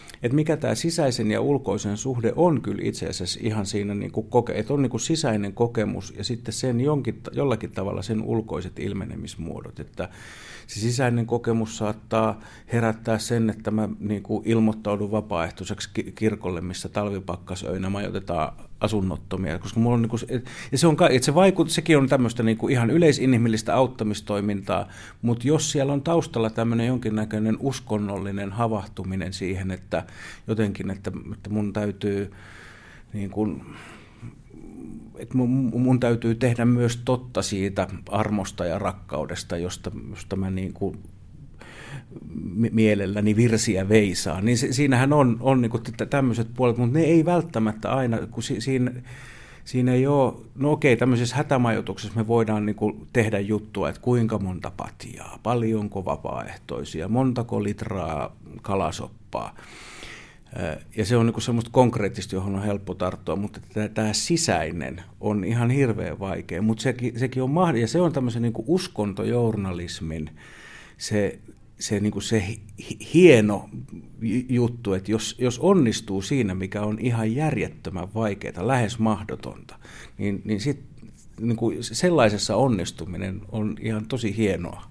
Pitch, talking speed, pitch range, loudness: 110 Hz, 130 wpm, 100-120 Hz, -24 LUFS